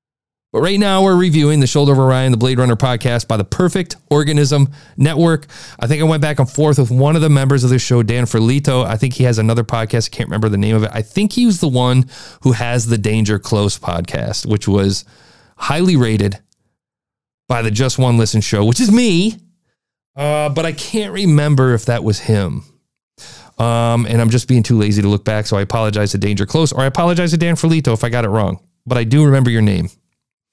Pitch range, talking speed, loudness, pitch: 110-150 Hz, 225 wpm, -15 LUFS, 125 Hz